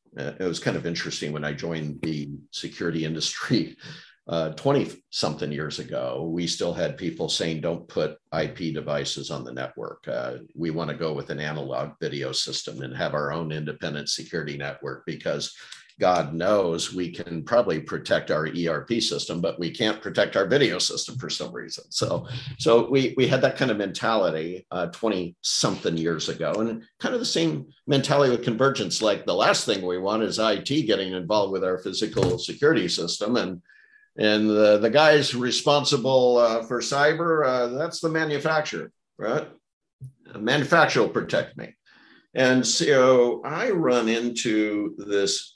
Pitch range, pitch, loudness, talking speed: 80-130 Hz, 105 Hz, -24 LUFS, 165 wpm